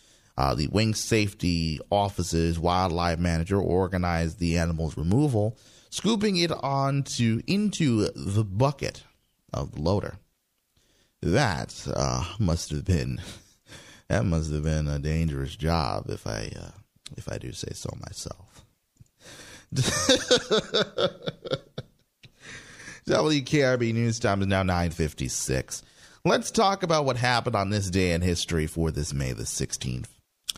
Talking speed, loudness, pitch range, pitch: 125 wpm, -26 LUFS, 80-115 Hz, 95 Hz